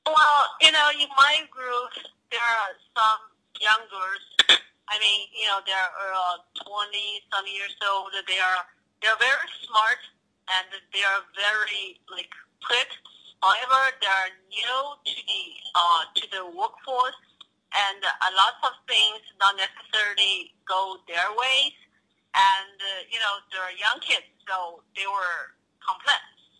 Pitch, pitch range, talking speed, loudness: 205 Hz, 195-250 Hz, 140 wpm, -23 LUFS